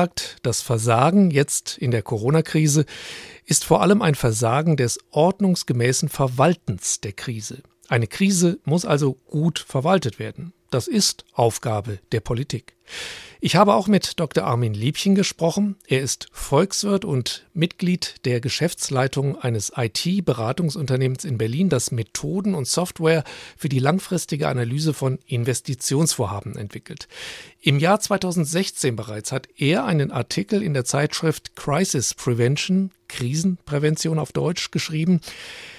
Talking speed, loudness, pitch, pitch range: 125 wpm, -21 LUFS, 150 Hz, 125-170 Hz